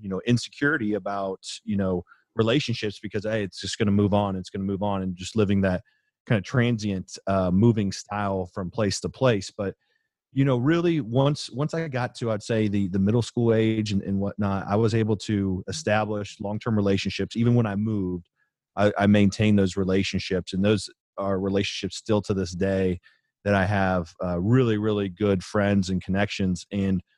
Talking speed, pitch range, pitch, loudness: 195 wpm, 95-110 Hz, 100 Hz, -25 LUFS